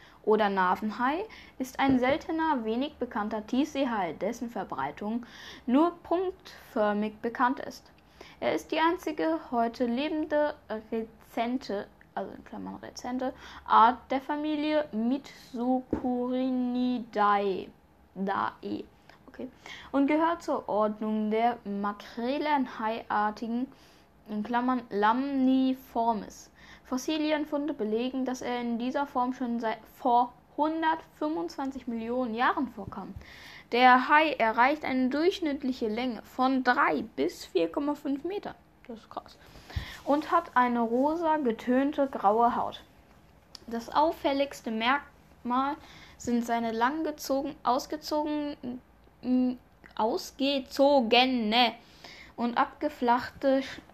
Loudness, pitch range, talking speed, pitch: -29 LUFS, 235-290 Hz, 95 wpm, 255 Hz